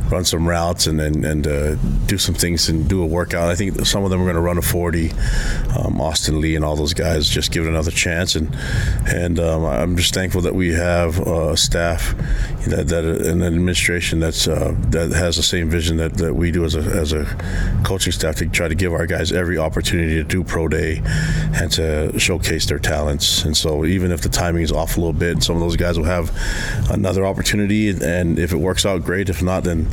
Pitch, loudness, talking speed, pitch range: 85 Hz, -18 LUFS, 230 wpm, 80-90 Hz